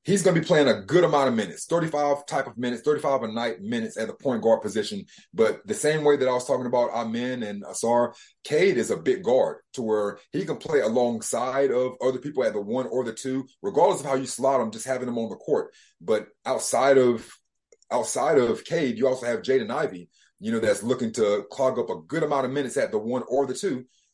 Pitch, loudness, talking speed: 135 Hz, -25 LUFS, 240 wpm